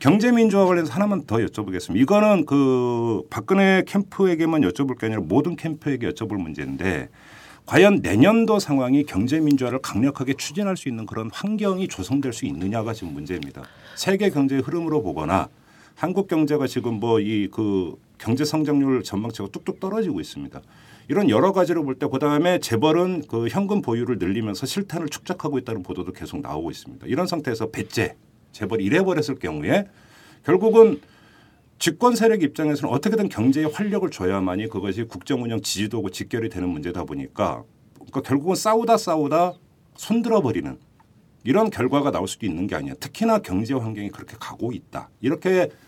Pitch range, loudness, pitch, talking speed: 115-185 Hz, -22 LUFS, 145 Hz, 395 characters per minute